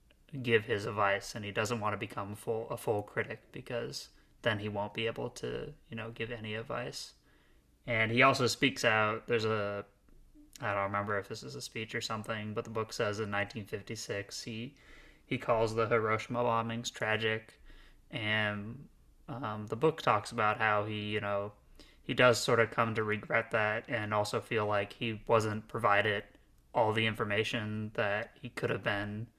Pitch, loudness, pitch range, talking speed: 110 Hz, -33 LUFS, 105-115 Hz, 180 wpm